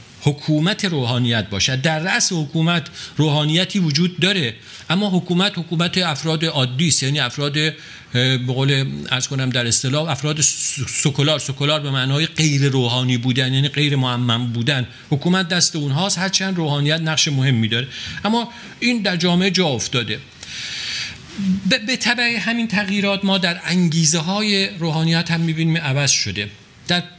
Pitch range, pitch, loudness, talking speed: 135-180 Hz, 155 Hz, -18 LUFS, 150 wpm